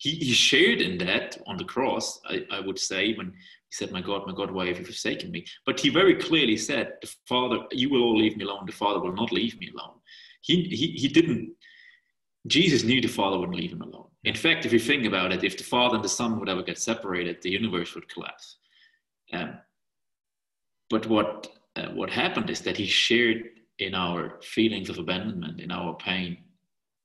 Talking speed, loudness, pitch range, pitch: 205 wpm, -25 LUFS, 100-155 Hz, 115 Hz